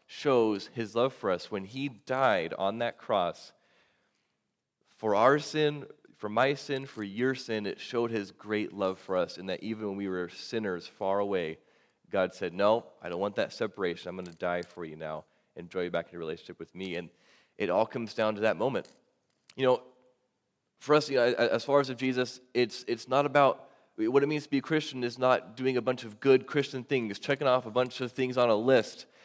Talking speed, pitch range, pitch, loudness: 220 wpm, 100-130 Hz, 125 Hz, -30 LUFS